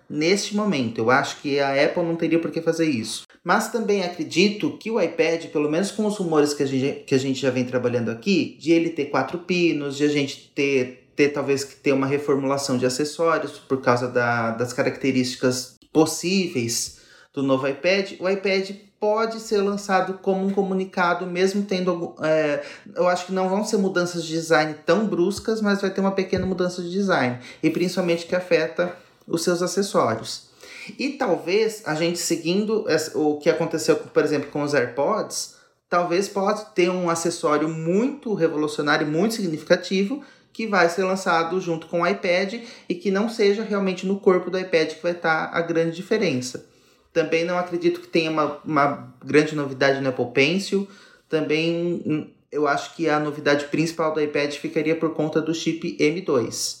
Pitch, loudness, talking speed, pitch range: 165 Hz, -23 LUFS, 180 wpm, 145-190 Hz